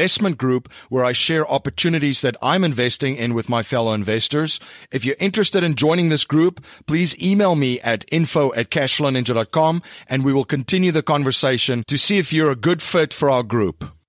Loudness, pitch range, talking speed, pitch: -19 LUFS, 125-165 Hz, 185 wpm, 140 Hz